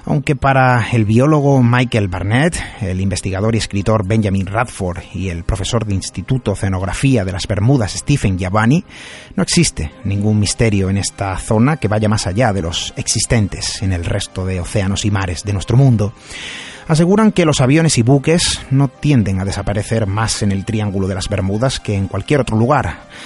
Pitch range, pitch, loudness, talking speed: 95-130 Hz, 110 Hz, -16 LUFS, 180 wpm